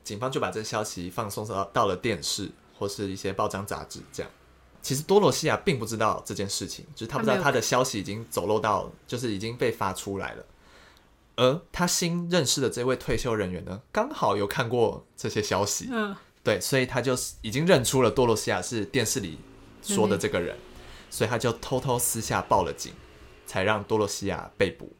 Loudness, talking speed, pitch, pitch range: -27 LUFS, 300 characters per minute, 115 Hz, 100-130 Hz